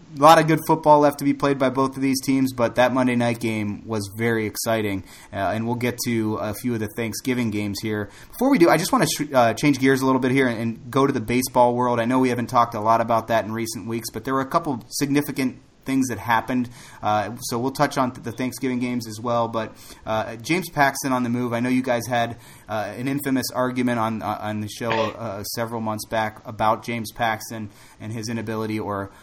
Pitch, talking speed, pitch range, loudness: 120 Hz, 245 wpm, 110-130 Hz, -22 LUFS